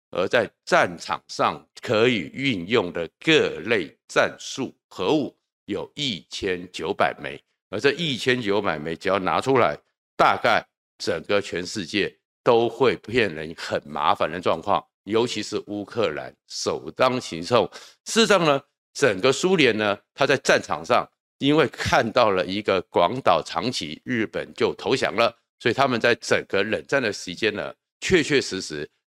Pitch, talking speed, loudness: 130 Hz, 225 characters per minute, -23 LUFS